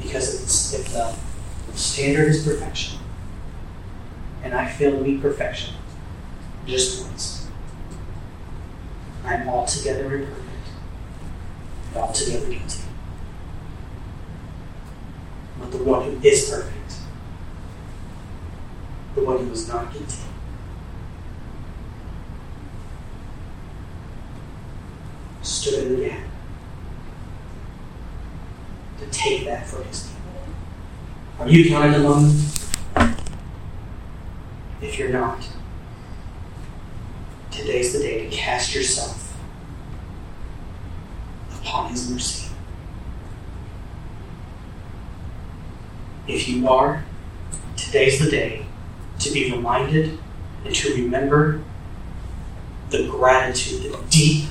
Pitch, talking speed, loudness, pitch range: 100 Hz, 80 wpm, -21 LUFS, 85-130 Hz